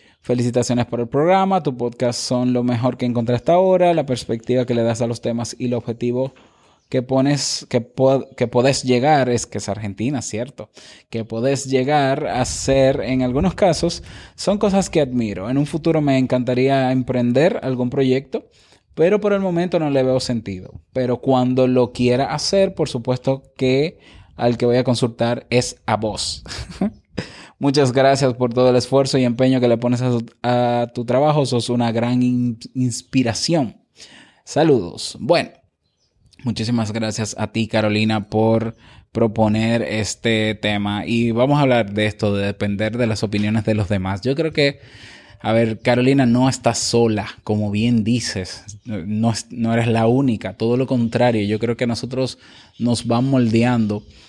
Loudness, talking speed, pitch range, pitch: -19 LUFS, 165 wpm, 115-130 Hz, 120 Hz